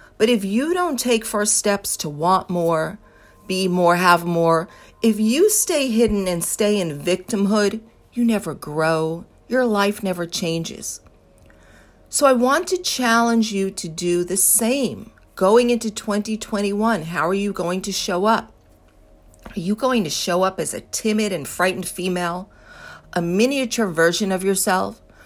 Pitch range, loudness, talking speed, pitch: 175-225 Hz, -20 LUFS, 155 wpm, 195 Hz